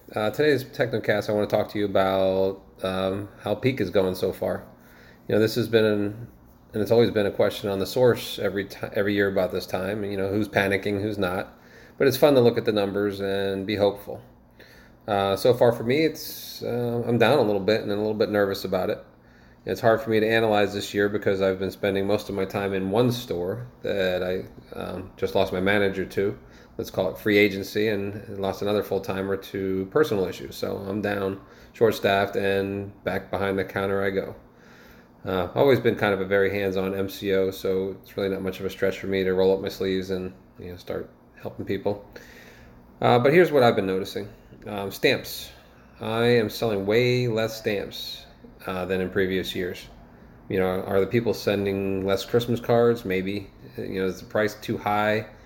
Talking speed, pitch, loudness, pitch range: 210 wpm, 100 Hz, -24 LUFS, 95-105 Hz